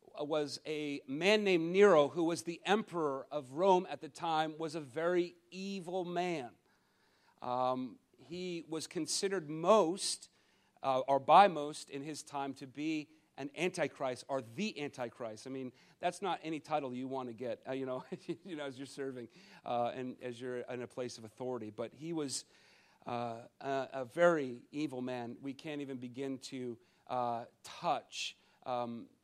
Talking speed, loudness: 165 wpm, -36 LUFS